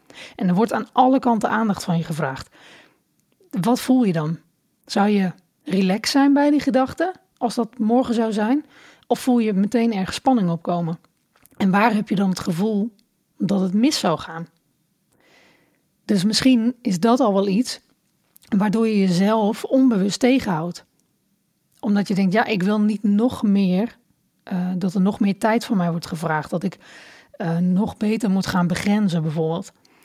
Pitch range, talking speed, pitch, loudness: 185-235 Hz, 170 wpm, 205 Hz, -20 LUFS